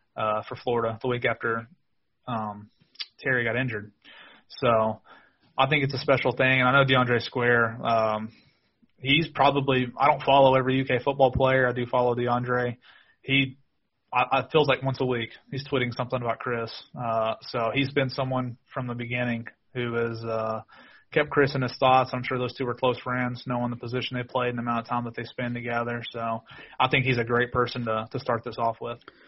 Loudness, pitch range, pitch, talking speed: -25 LUFS, 115-130 Hz, 125 Hz, 205 wpm